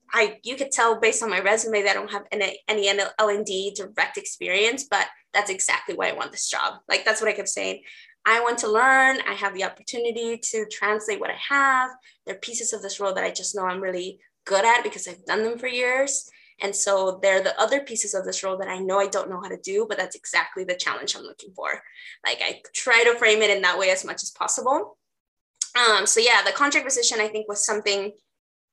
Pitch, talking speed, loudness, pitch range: 215 Hz, 240 wpm, -23 LUFS, 195-250 Hz